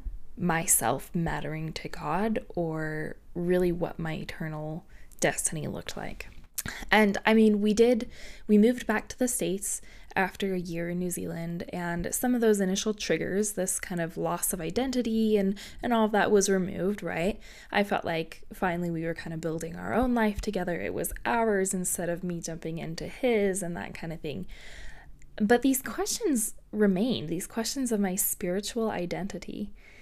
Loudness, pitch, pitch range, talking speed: -28 LUFS, 190 Hz, 170-220 Hz, 170 wpm